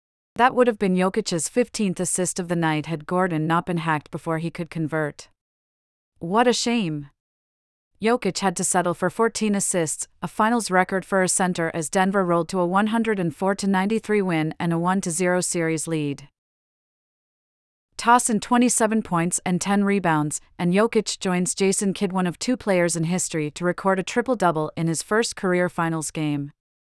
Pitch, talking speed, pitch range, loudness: 180 Hz, 175 wpm, 165-200 Hz, -22 LUFS